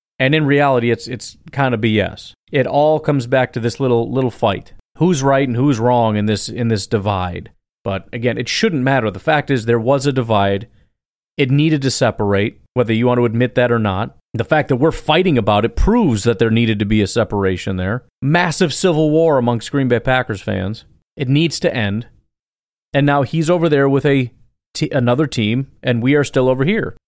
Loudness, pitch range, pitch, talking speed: -16 LUFS, 110-140 Hz, 125 Hz, 210 wpm